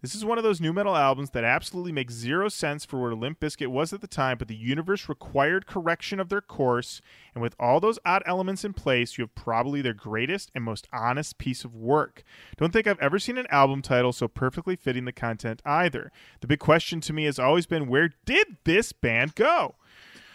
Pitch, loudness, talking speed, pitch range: 145 Hz, -26 LUFS, 220 wpm, 125-180 Hz